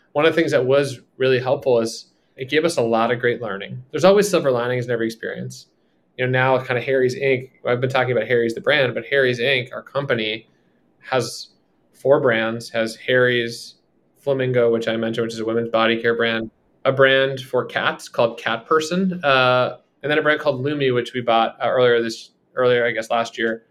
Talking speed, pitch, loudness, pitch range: 210 wpm, 125 Hz, -20 LUFS, 115-135 Hz